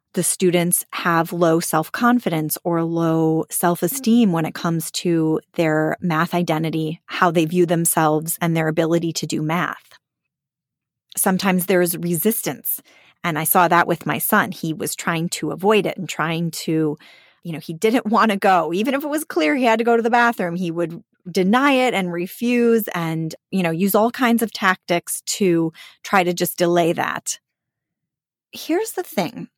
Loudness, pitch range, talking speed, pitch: -19 LUFS, 165-205 Hz, 180 wpm, 175 Hz